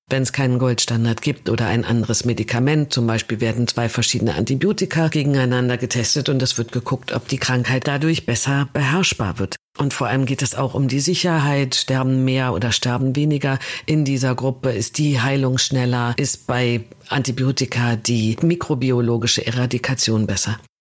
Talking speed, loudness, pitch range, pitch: 160 wpm, -19 LUFS, 120-140 Hz, 130 Hz